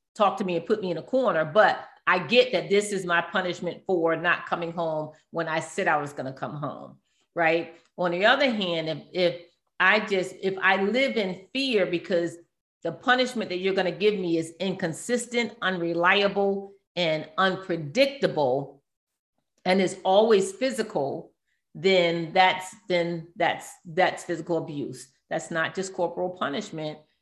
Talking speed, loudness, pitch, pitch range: 165 wpm, -25 LUFS, 180 Hz, 165-195 Hz